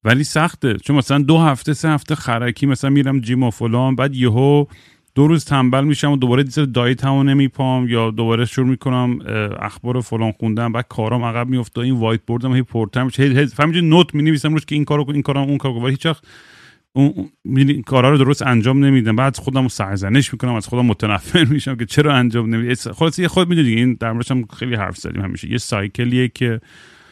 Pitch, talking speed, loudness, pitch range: 130 Hz, 200 wpm, -17 LUFS, 120-140 Hz